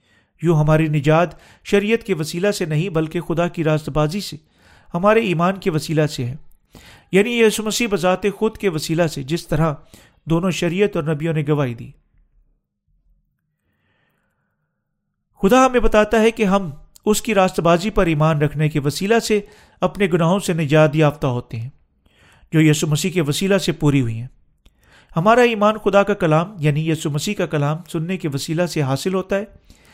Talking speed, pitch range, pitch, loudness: 170 wpm, 155-200 Hz, 170 Hz, -18 LUFS